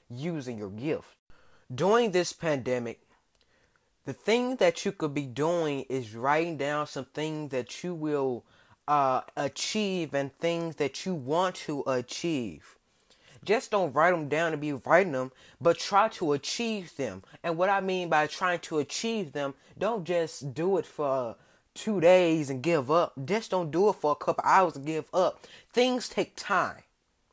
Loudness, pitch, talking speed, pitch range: -28 LUFS, 155 Hz, 170 wpm, 140-185 Hz